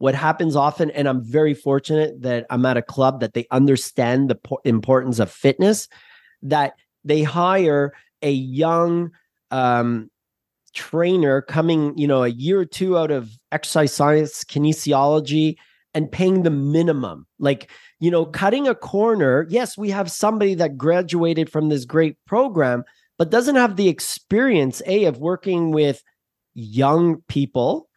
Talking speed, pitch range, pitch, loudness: 150 wpm, 135-170 Hz, 155 Hz, -19 LUFS